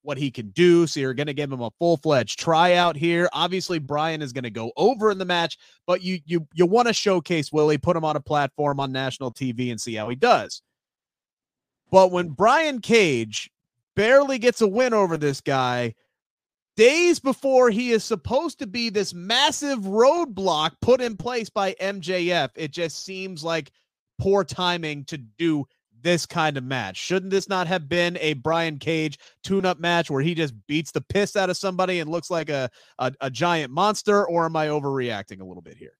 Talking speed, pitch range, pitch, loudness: 200 wpm, 145-195 Hz, 170 Hz, -22 LUFS